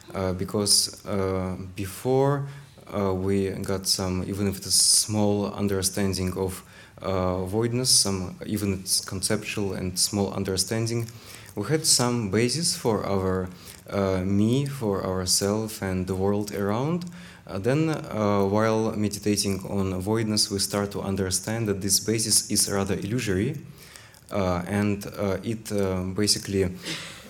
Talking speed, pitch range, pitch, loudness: 130 wpm, 95-110 Hz, 100 Hz, -25 LUFS